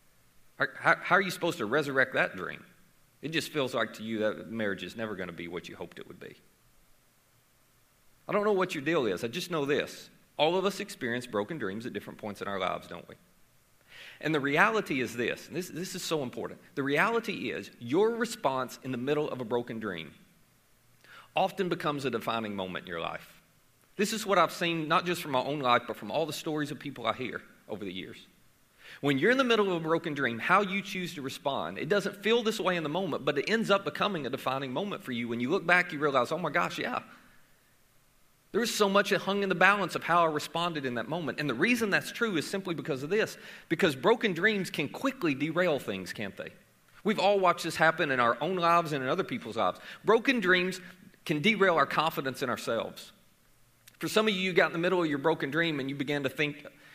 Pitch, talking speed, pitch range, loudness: 165 Hz, 235 wpm, 130-195 Hz, -29 LUFS